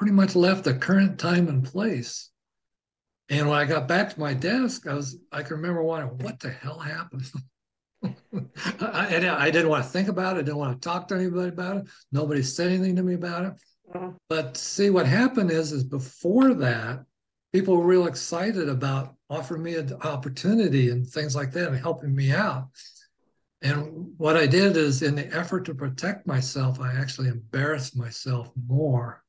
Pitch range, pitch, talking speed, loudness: 135-180 Hz, 155 Hz, 190 wpm, -25 LUFS